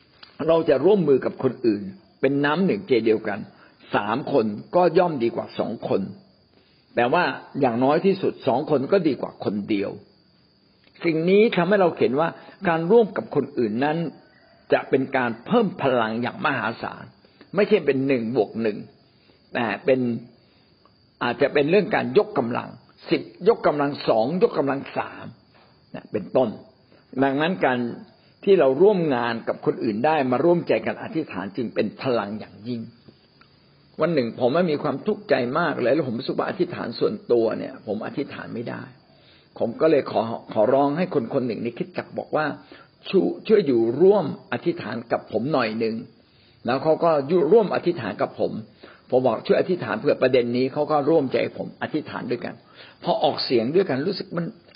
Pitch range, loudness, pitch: 120-180 Hz, -23 LUFS, 150 Hz